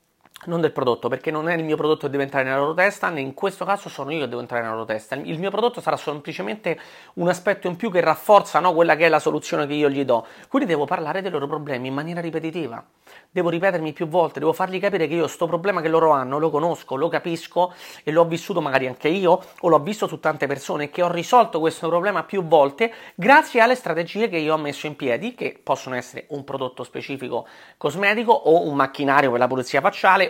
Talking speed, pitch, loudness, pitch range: 230 wpm, 160 Hz, -21 LUFS, 145-180 Hz